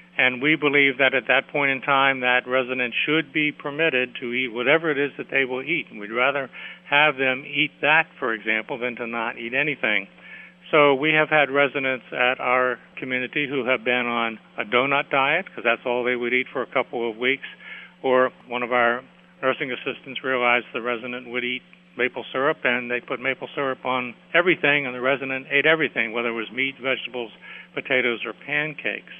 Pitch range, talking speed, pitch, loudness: 125-145 Hz, 195 wpm, 130 Hz, -22 LUFS